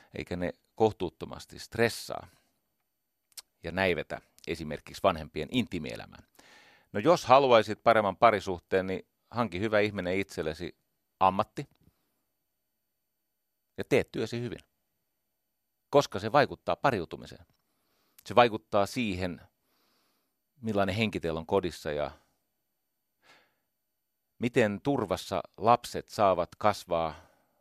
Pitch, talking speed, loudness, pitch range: 105 Hz, 90 wpm, -29 LUFS, 95-115 Hz